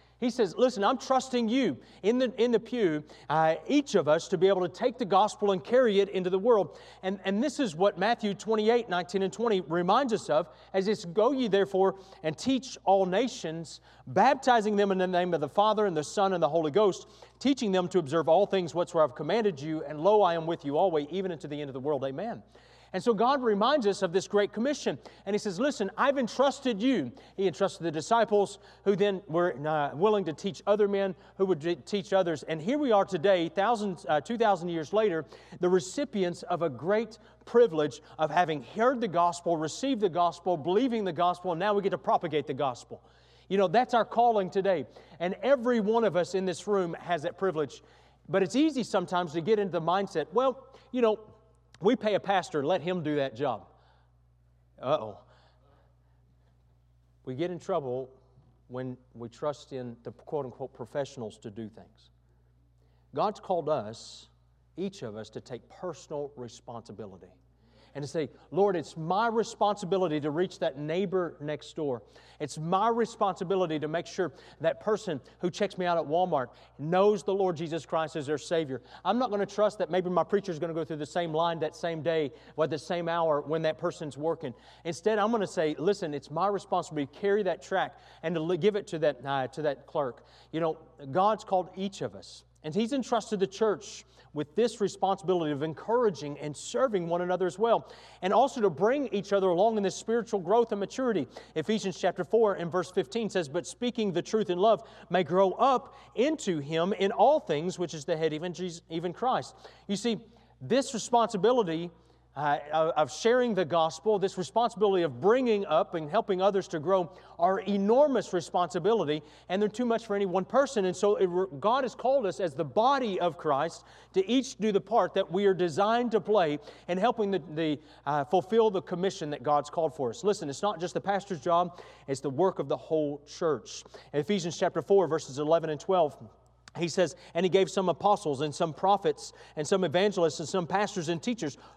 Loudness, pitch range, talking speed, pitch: -29 LUFS, 155-205 Hz, 205 wpm, 185 Hz